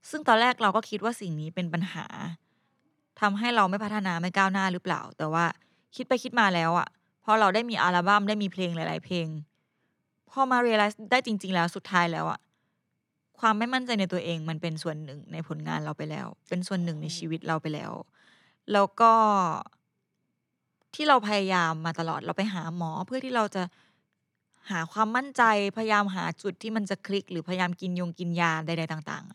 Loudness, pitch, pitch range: -27 LUFS, 185 Hz, 170-215 Hz